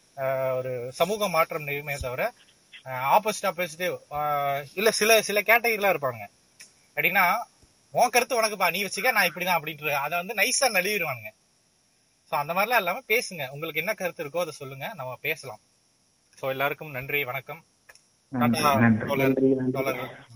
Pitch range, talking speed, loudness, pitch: 135-195 Hz, 110 wpm, -25 LUFS, 155 Hz